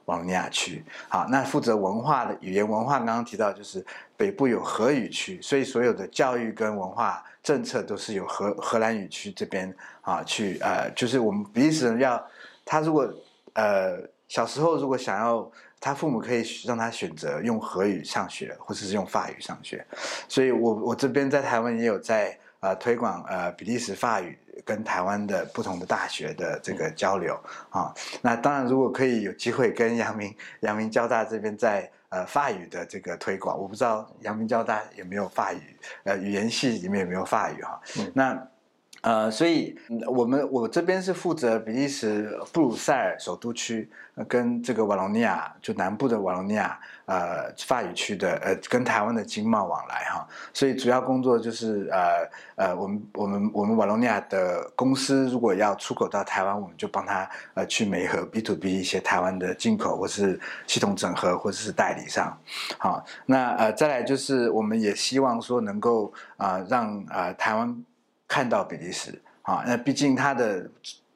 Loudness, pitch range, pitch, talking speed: -26 LUFS, 110-140 Hz, 120 Hz, 280 characters per minute